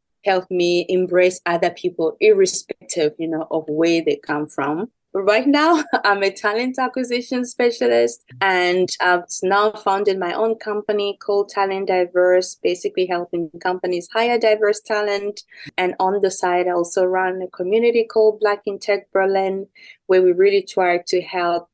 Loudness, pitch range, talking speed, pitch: -19 LUFS, 180-210 Hz, 155 wpm, 190 Hz